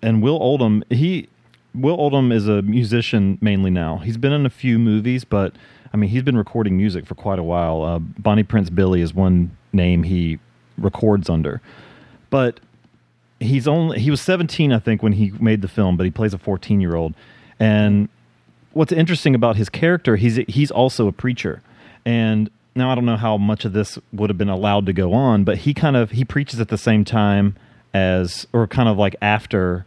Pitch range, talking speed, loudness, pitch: 95-125 Hz, 205 wpm, -19 LUFS, 110 Hz